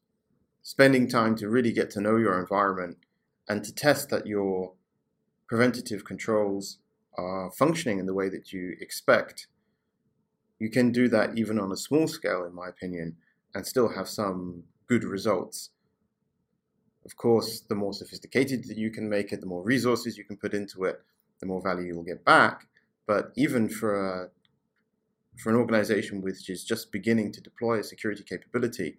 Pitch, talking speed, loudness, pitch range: 105 Hz, 170 wpm, -27 LUFS, 95-115 Hz